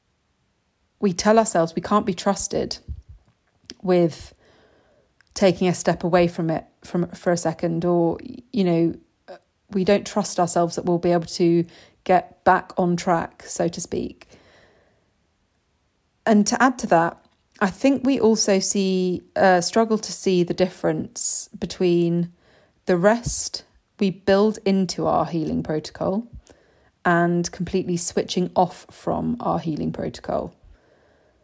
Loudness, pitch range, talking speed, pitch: -22 LUFS, 175-200 Hz, 130 wpm, 180 Hz